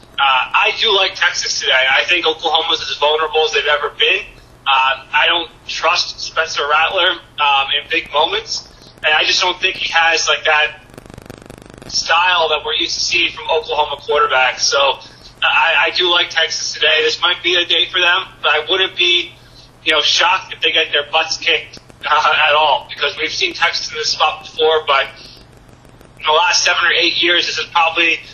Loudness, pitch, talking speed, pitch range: -14 LUFS, 160 Hz, 195 wpm, 150-175 Hz